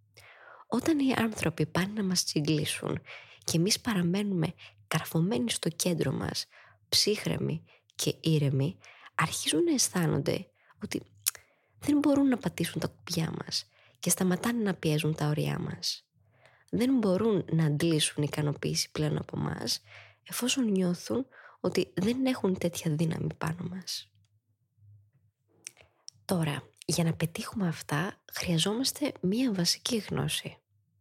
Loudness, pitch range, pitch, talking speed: -30 LUFS, 145-200 Hz, 170 Hz, 120 wpm